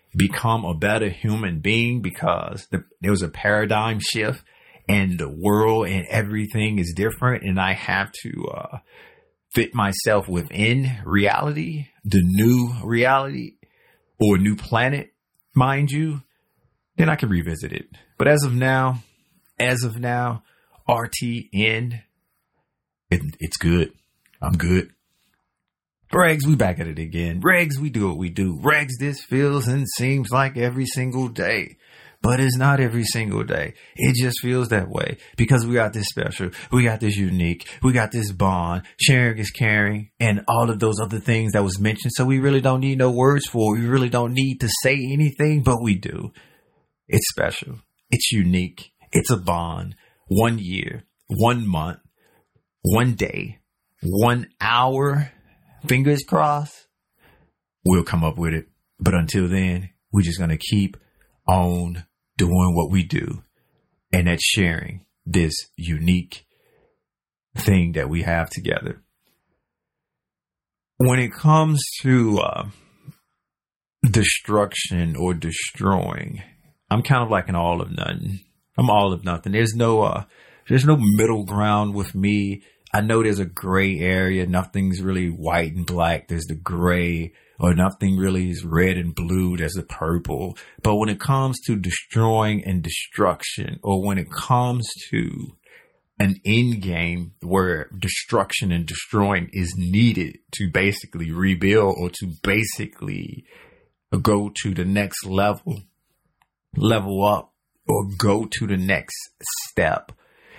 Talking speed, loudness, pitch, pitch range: 145 wpm, -21 LUFS, 105 Hz, 90-120 Hz